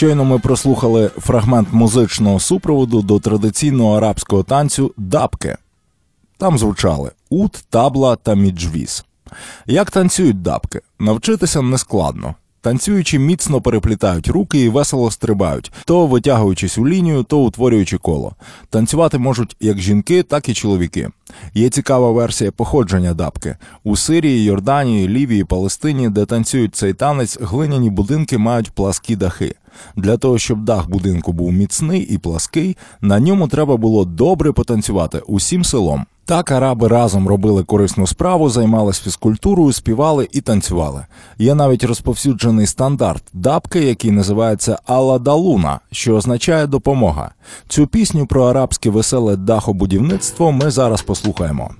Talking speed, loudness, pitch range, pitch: 130 wpm, -15 LUFS, 100-140 Hz, 115 Hz